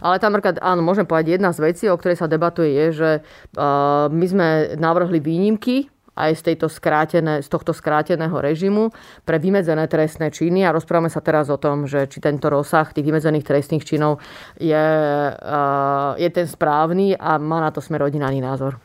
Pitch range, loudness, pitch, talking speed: 150-170 Hz, -19 LUFS, 160 Hz, 175 wpm